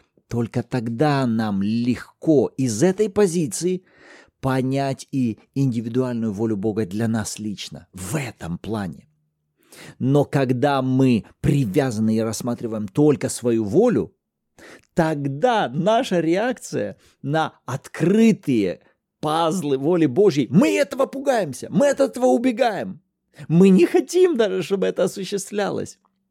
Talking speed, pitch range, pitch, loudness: 110 wpm, 120-190 Hz, 140 Hz, -21 LUFS